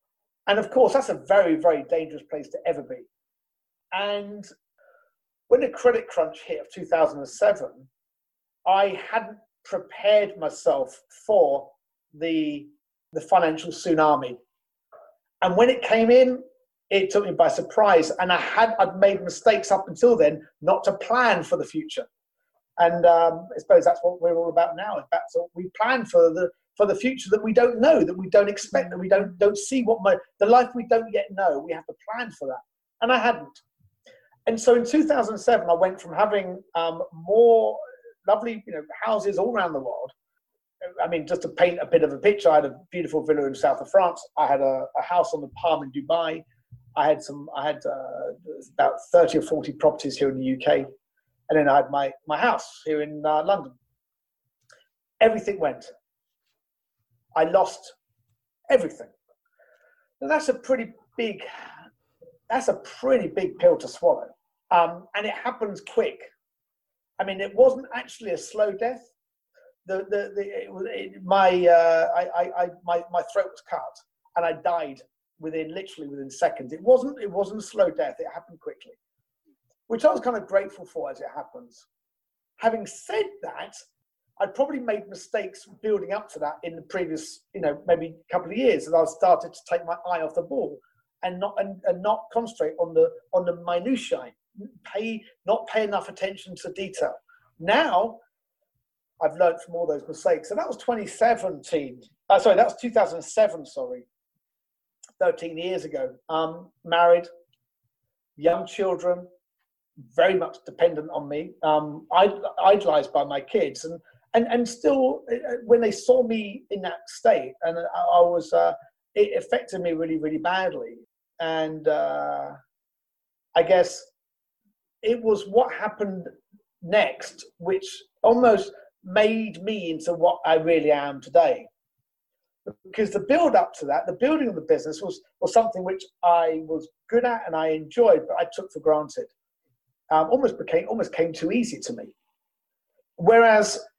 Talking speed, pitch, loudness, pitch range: 170 wpm, 200 Hz, -23 LUFS, 170-255 Hz